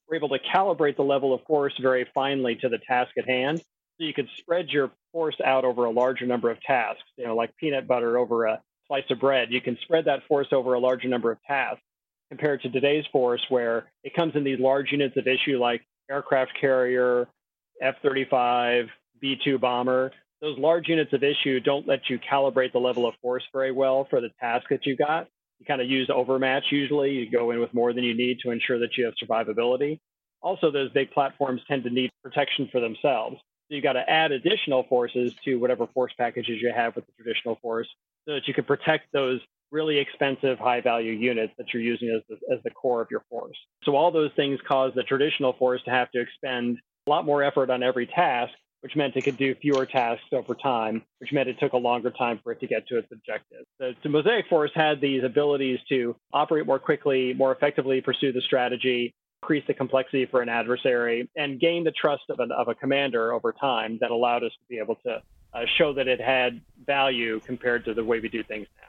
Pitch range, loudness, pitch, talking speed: 120-140 Hz, -25 LUFS, 130 Hz, 220 wpm